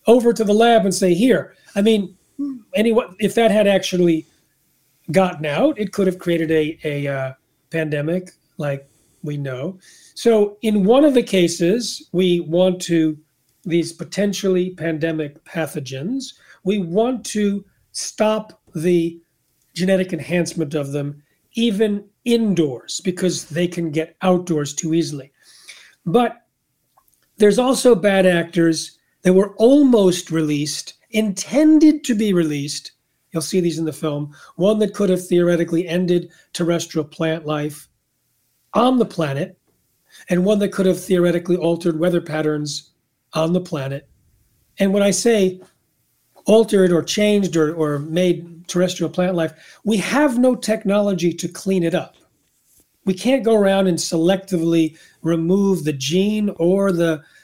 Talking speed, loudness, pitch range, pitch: 140 wpm, -19 LUFS, 160-205 Hz, 180 Hz